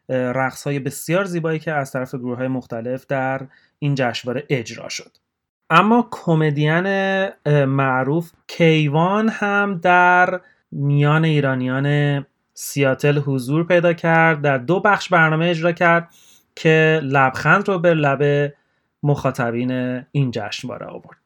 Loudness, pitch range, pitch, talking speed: -18 LUFS, 135-170 Hz, 145 Hz, 120 wpm